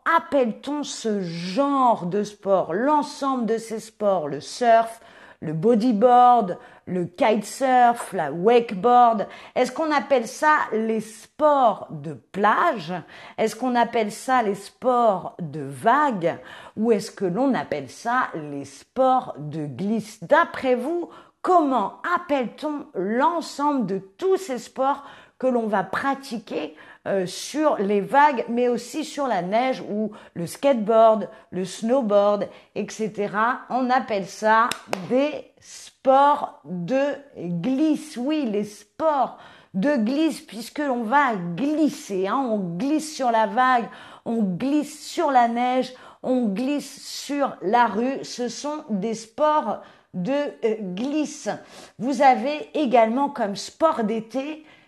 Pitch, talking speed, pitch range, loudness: 240 Hz, 125 wpm, 205-275 Hz, -22 LUFS